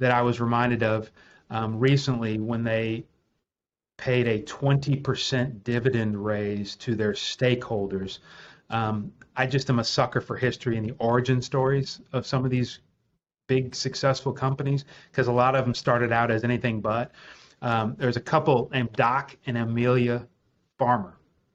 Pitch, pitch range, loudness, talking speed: 120 Hz, 115-130 Hz, -26 LUFS, 155 wpm